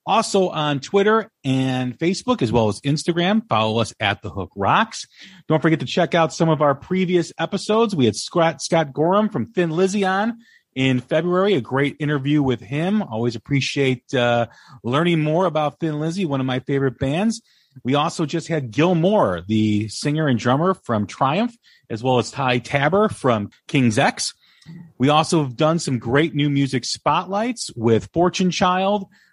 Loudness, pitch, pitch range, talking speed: -20 LUFS, 150 Hz, 130-180 Hz, 175 wpm